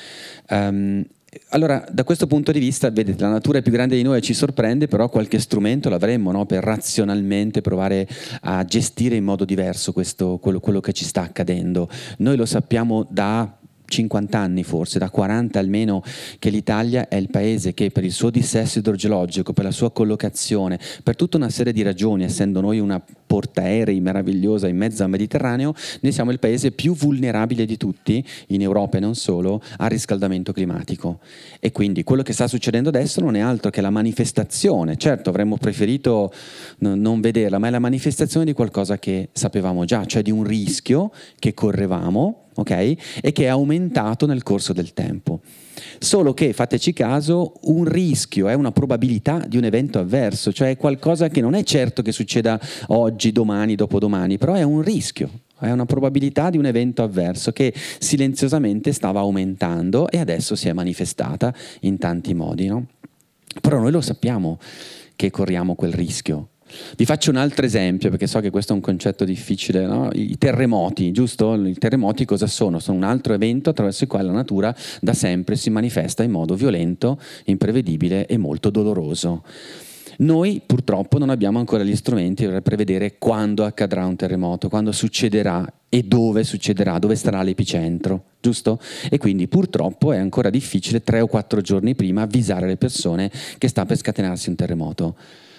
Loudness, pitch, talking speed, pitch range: -20 LUFS, 110 Hz, 175 wpm, 100-125 Hz